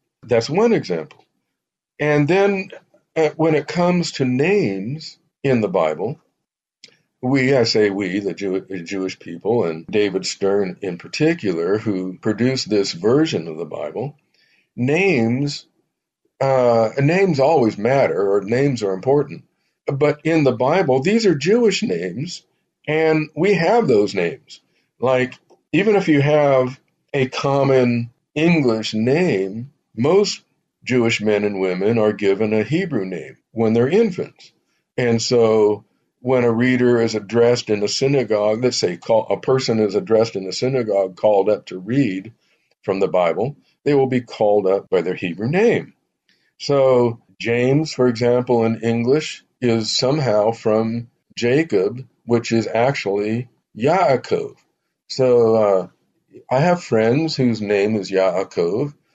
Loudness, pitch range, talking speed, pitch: -18 LUFS, 105-150 Hz, 135 wpm, 125 Hz